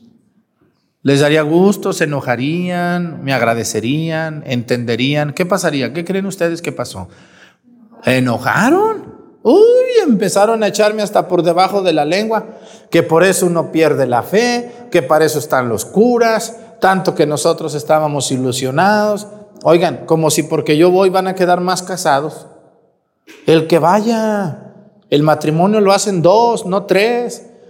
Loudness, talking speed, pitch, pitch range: -14 LUFS, 140 wpm, 180 Hz, 155-210 Hz